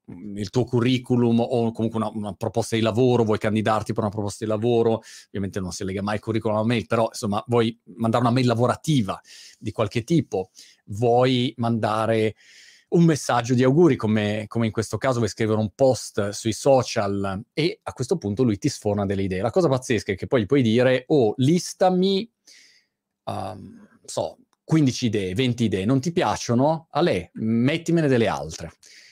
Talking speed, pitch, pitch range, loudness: 180 wpm, 115 Hz, 110-130 Hz, -23 LUFS